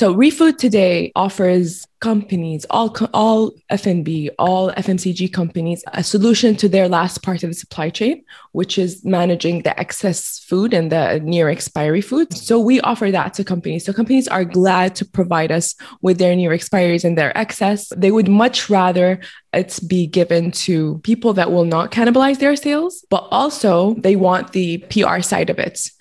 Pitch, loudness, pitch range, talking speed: 185 Hz, -16 LUFS, 175-220 Hz, 175 wpm